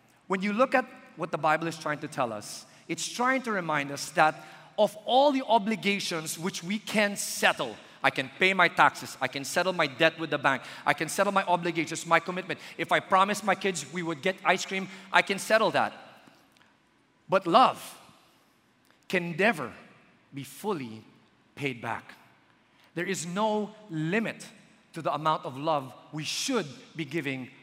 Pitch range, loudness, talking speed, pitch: 155-205 Hz, -28 LUFS, 175 wpm, 175 Hz